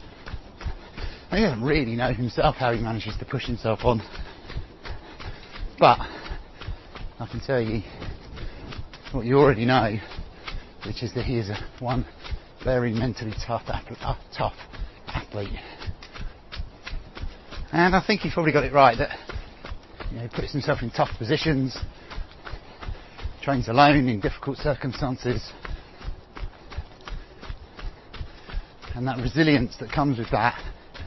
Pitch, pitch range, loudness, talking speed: 125 Hz, 115-140 Hz, -24 LUFS, 120 wpm